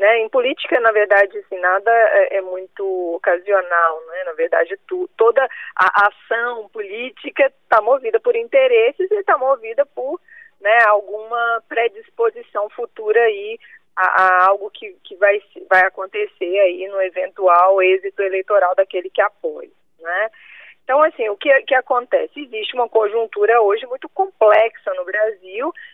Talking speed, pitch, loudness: 145 wpm, 235 Hz, -17 LUFS